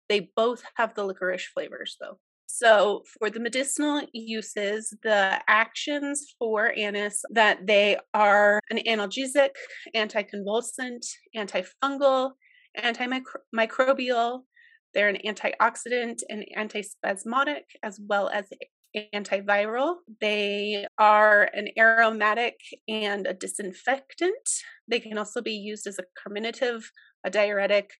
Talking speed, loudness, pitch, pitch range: 105 wpm, -25 LUFS, 220 Hz, 205-260 Hz